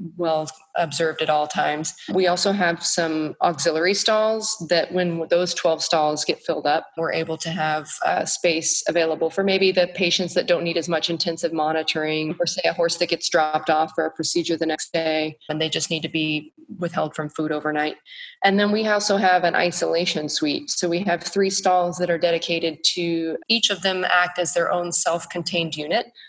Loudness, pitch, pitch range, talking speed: -22 LUFS, 170 Hz, 160-180 Hz, 200 wpm